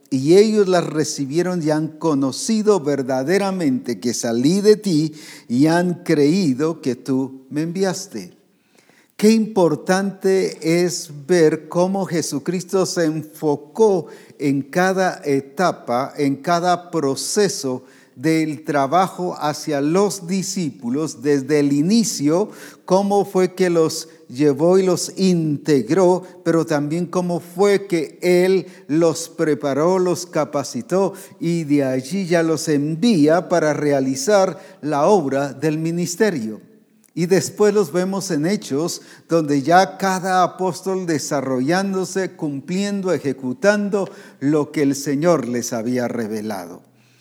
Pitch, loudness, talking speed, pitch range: 165 Hz, -19 LUFS, 115 wpm, 145-185 Hz